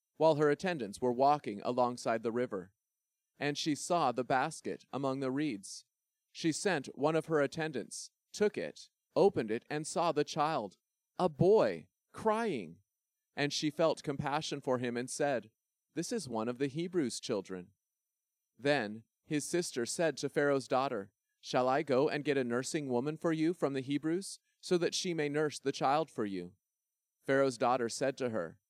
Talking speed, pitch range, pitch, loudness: 170 wpm, 125-160 Hz, 145 Hz, -34 LUFS